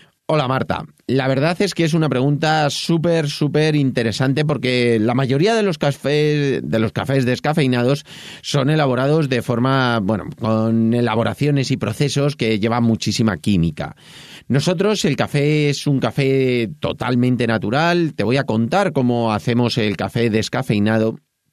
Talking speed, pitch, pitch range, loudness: 145 wpm, 130 Hz, 115-150 Hz, -18 LUFS